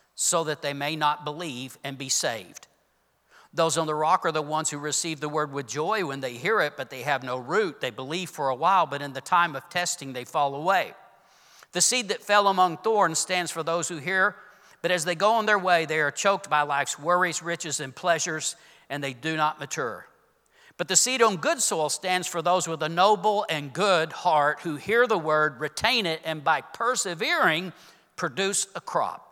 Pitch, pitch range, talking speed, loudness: 165 Hz, 150-185 Hz, 215 wpm, -25 LUFS